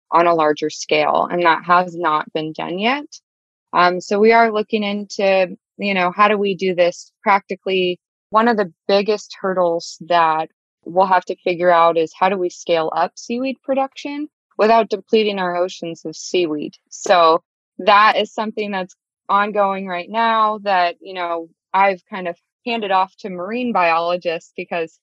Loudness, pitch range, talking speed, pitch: -18 LUFS, 170-210 Hz, 170 wpm, 185 Hz